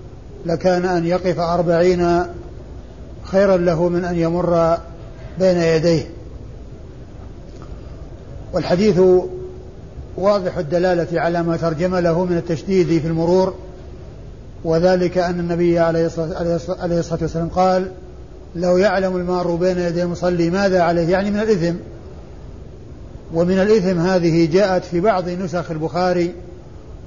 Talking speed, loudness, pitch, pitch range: 105 wpm, -18 LUFS, 175 Hz, 165-180 Hz